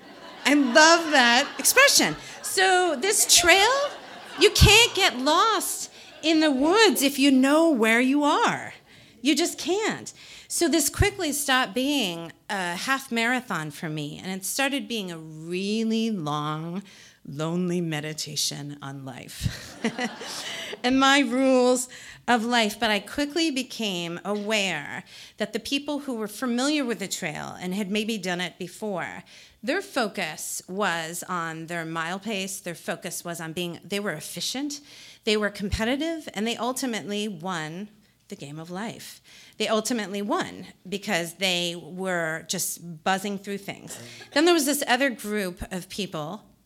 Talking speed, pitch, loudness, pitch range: 145 wpm, 215 Hz, -24 LUFS, 180-275 Hz